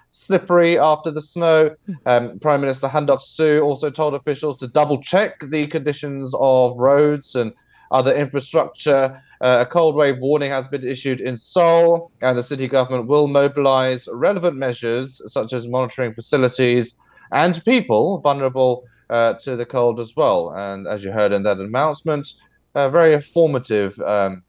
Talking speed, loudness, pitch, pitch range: 155 wpm, -18 LUFS, 135 Hz, 125-150 Hz